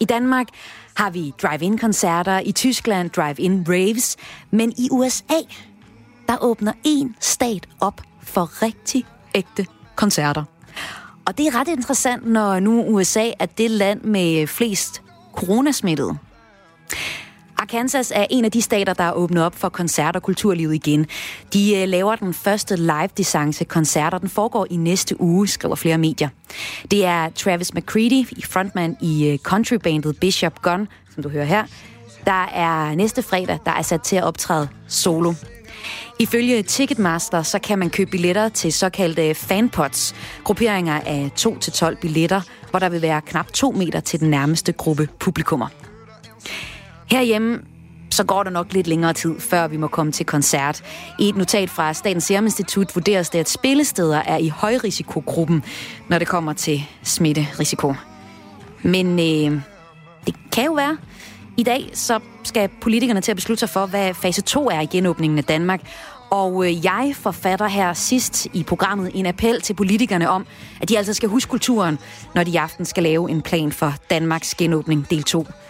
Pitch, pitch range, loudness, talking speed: 185 Hz, 165-215 Hz, -20 LUFS, 160 wpm